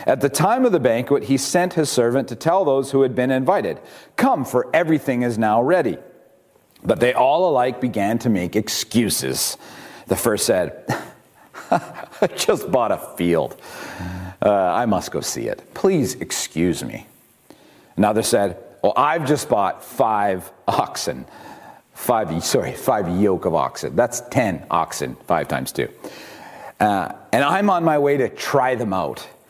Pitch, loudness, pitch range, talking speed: 125 Hz, -20 LUFS, 105-140 Hz, 160 wpm